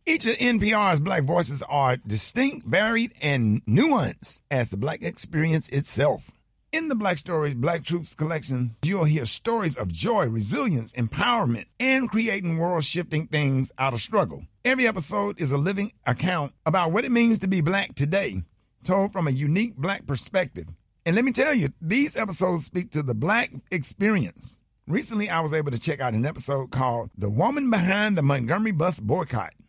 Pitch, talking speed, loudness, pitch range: 165 Hz, 175 wpm, -24 LUFS, 135-210 Hz